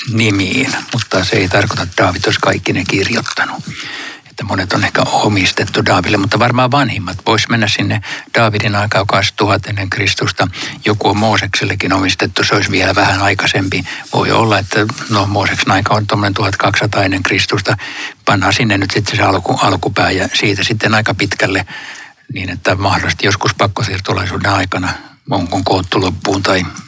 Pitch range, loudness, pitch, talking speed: 100-110 Hz, -13 LUFS, 100 Hz, 155 wpm